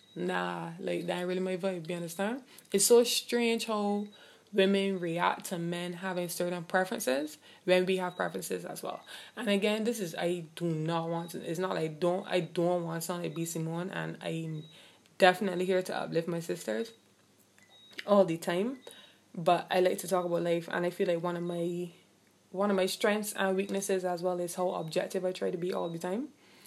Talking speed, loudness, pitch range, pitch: 205 wpm, -31 LUFS, 170-195 Hz, 180 Hz